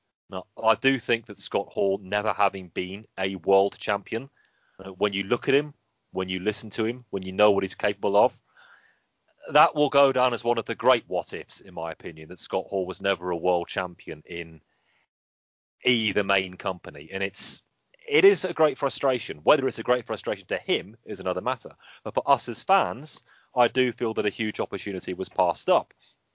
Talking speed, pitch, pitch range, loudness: 200 wpm, 105 Hz, 95-125 Hz, -25 LUFS